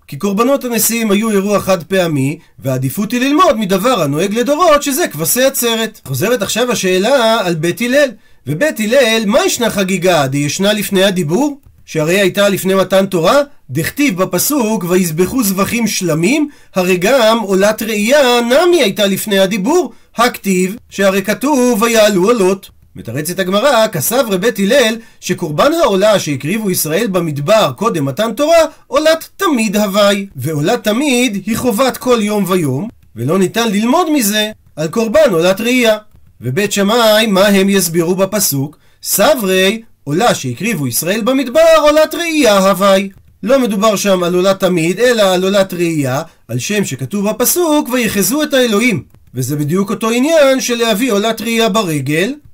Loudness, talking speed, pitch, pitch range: -13 LUFS, 145 wpm, 205 Hz, 185-245 Hz